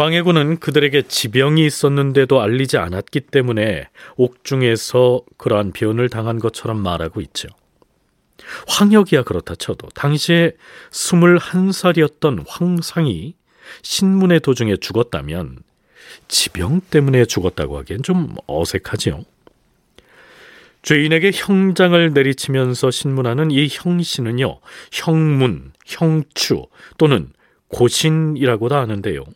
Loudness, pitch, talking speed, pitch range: -16 LUFS, 140 Hz, 260 characters per minute, 115-160 Hz